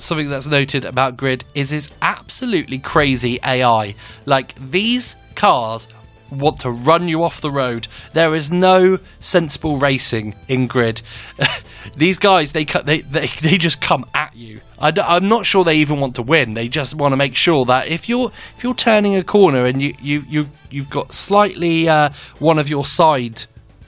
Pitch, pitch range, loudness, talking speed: 145 Hz, 125-165 Hz, -16 LUFS, 180 wpm